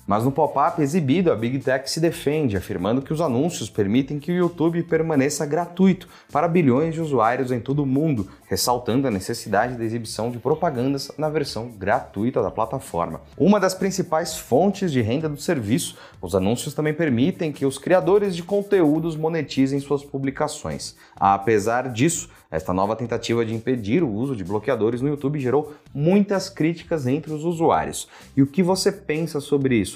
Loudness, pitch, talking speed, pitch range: -22 LUFS, 145 Hz, 170 wpm, 120-165 Hz